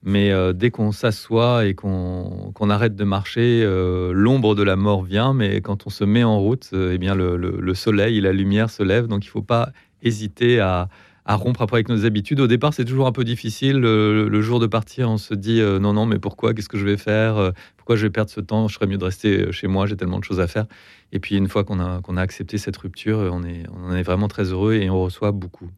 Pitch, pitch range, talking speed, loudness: 105 Hz, 95-110 Hz, 270 wpm, -20 LUFS